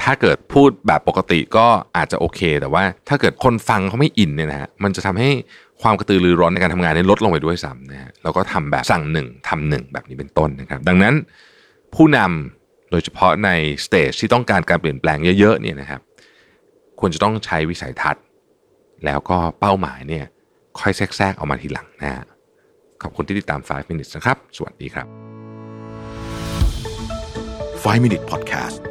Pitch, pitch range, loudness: 95 Hz, 80-110 Hz, -18 LUFS